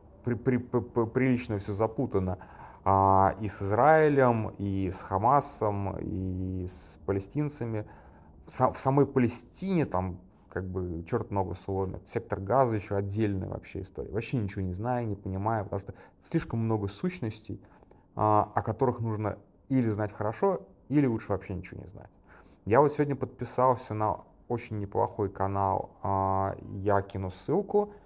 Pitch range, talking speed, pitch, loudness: 95-120 Hz, 145 wpm, 105 Hz, -29 LUFS